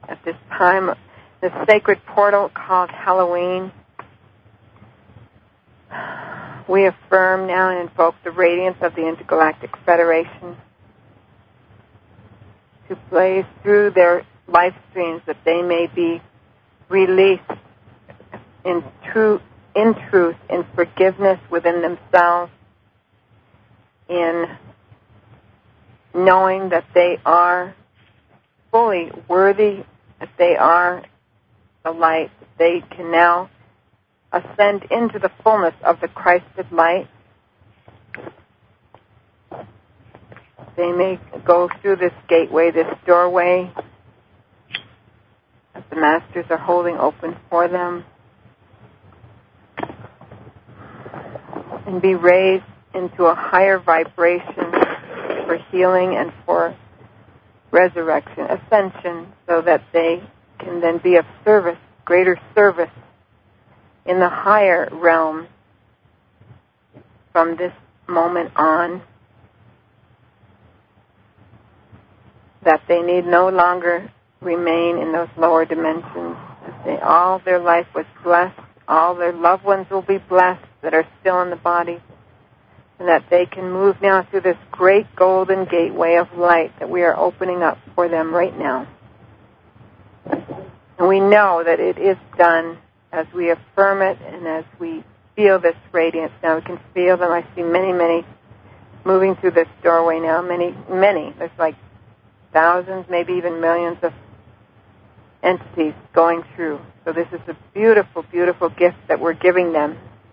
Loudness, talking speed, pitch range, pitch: -17 LUFS, 115 wpm, 115-180 Hz, 170 Hz